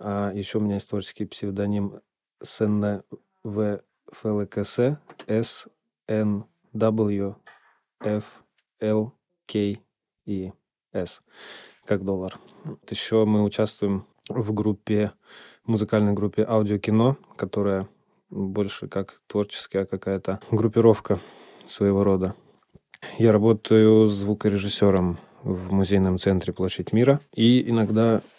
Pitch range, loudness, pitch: 100-110 Hz, -24 LUFS, 105 Hz